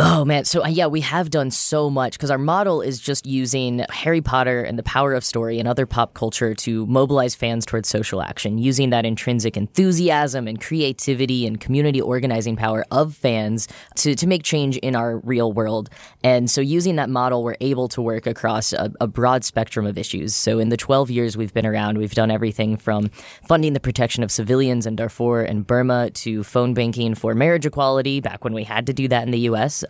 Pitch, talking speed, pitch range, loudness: 120 Hz, 210 wpm, 115-135 Hz, -20 LUFS